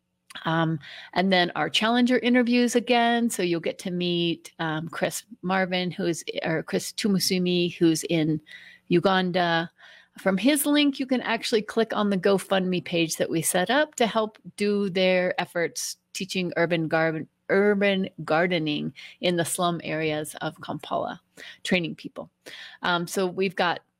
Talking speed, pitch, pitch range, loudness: 150 wpm, 180 Hz, 165-210 Hz, -25 LUFS